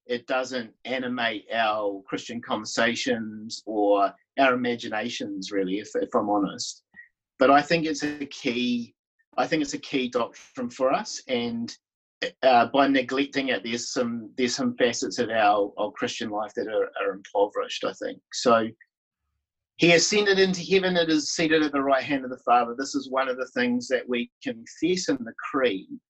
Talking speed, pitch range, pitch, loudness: 175 wpm, 120-180 Hz, 135 Hz, -25 LUFS